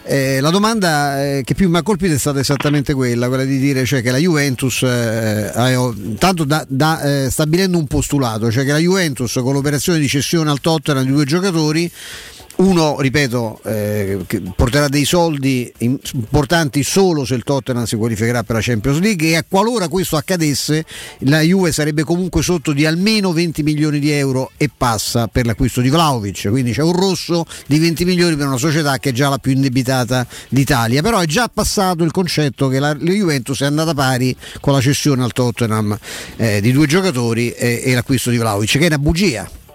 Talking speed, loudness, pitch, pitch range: 190 wpm, -16 LUFS, 140 Hz, 125-165 Hz